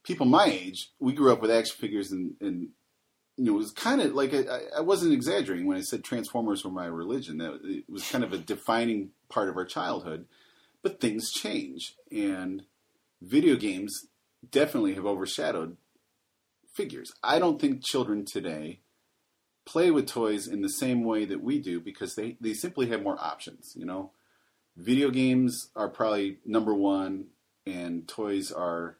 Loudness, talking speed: -29 LUFS, 170 wpm